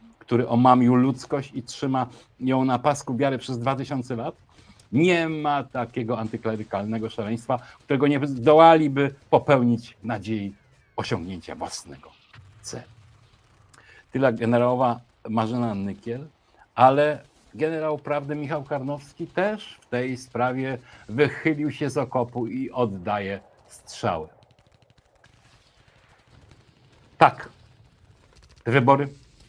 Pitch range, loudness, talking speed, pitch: 115-140 Hz, -24 LUFS, 95 wpm, 125 Hz